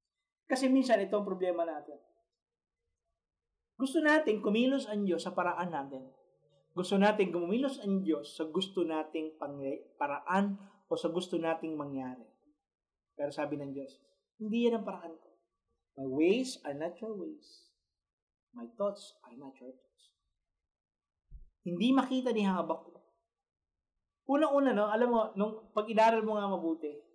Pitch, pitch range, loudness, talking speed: 190 Hz, 155-225 Hz, -32 LUFS, 135 wpm